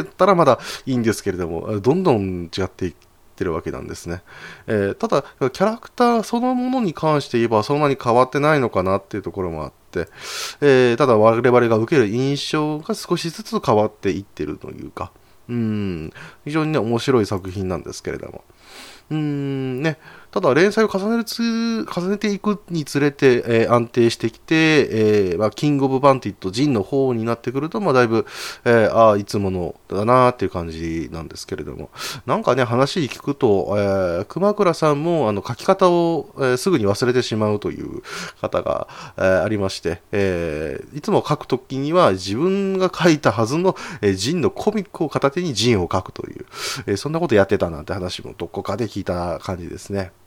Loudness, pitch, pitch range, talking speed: -20 LUFS, 125 Hz, 100-160 Hz, 395 characters per minute